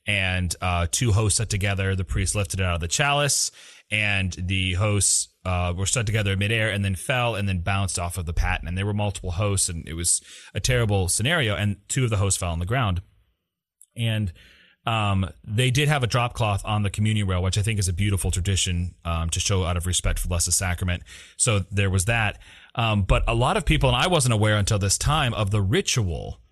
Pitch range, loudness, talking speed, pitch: 90-110 Hz, -23 LUFS, 230 wpm, 100 Hz